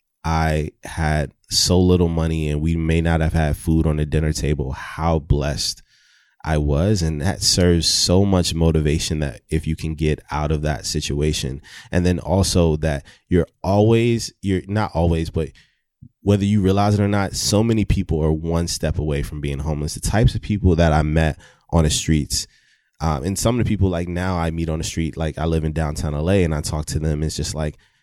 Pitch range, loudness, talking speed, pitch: 75-90 Hz, -20 LUFS, 210 wpm, 80 Hz